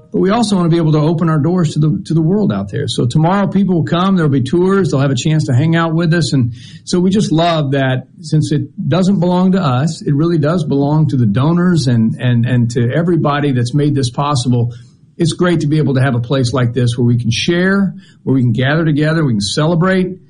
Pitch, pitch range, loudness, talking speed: 155 Hz, 135-175 Hz, -14 LUFS, 255 wpm